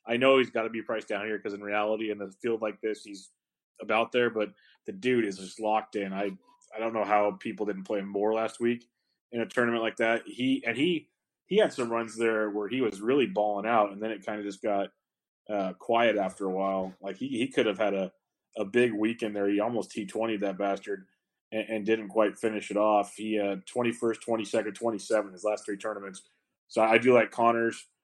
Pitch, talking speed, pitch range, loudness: 110 Hz, 240 wpm, 100-115 Hz, -29 LUFS